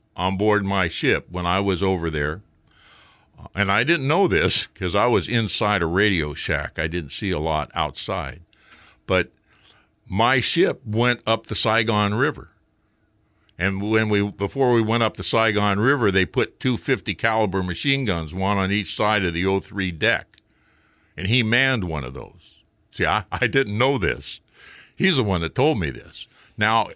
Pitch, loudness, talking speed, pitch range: 105 Hz, -21 LUFS, 180 wpm, 90-115 Hz